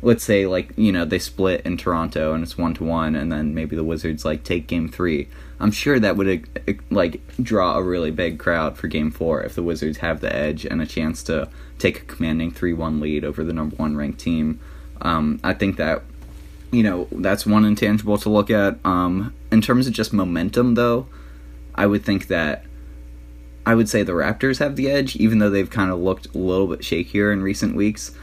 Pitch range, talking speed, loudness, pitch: 75-105 Hz, 215 wpm, -21 LUFS, 85 Hz